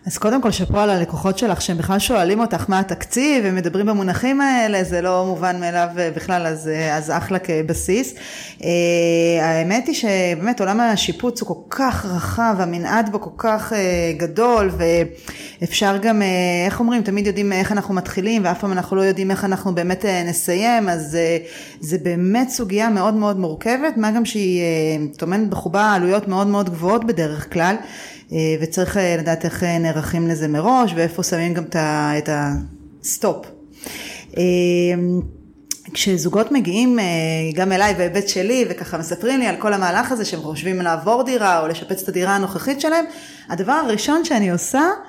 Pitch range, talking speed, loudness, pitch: 170-215 Hz, 155 wpm, -19 LUFS, 185 Hz